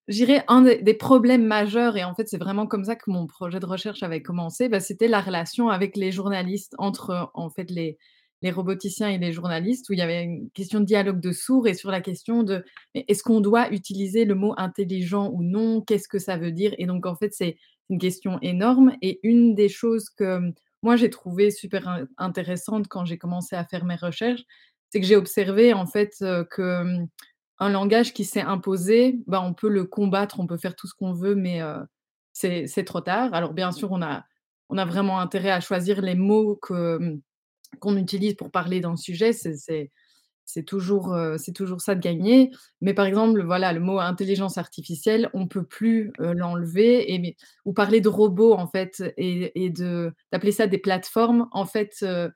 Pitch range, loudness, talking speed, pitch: 180-215 Hz, -23 LUFS, 205 wpm, 195 Hz